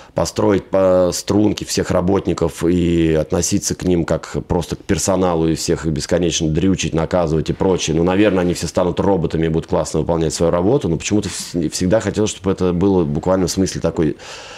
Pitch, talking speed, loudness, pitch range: 90 Hz, 175 wpm, -17 LUFS, 80-95 Hz